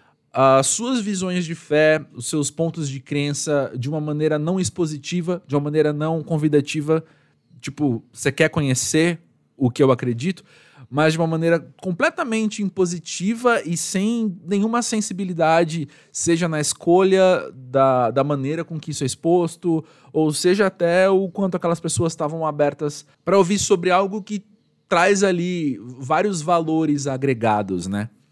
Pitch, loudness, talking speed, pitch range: 160 Hz, -20 LUFS, 145 wpm, 145-185 Hz